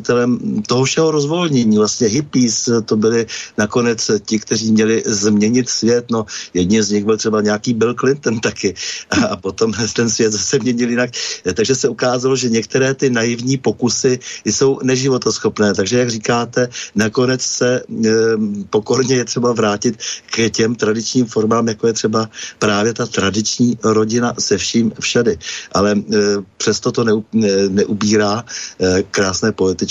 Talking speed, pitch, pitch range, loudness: 140 wpm, 115 Hz, 110-125 Hz, -16 LUFS